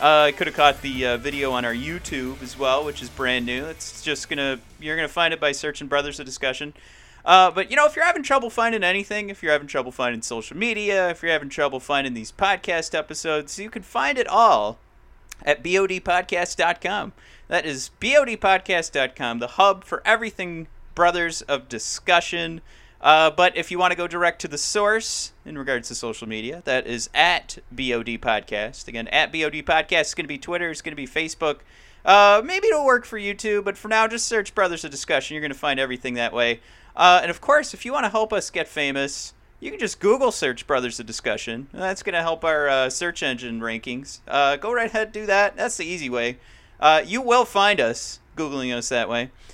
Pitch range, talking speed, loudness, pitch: 130-195 Hz, 215 wpm, -21 LUFS, 155 Hz